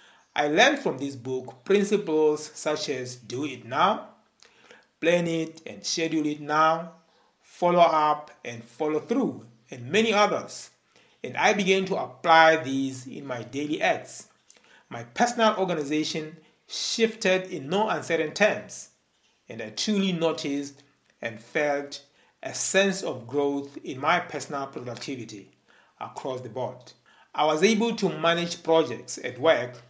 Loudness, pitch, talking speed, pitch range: -25 LUFS, 155 Hz, 135 wpm, 140-180 Hz